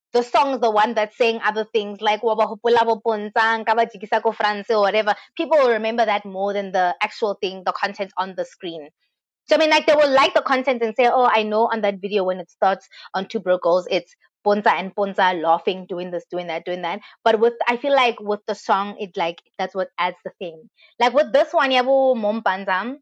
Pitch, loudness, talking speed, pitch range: 215 Hz, -20 LUFS, 215 wpm, 190-235 Hz